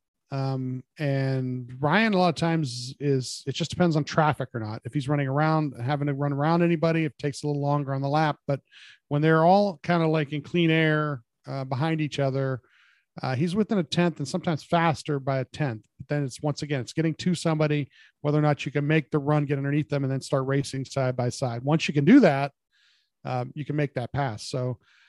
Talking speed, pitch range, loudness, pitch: 230 wpm, 135-160 Hz, -26 LUFS, 145 Hz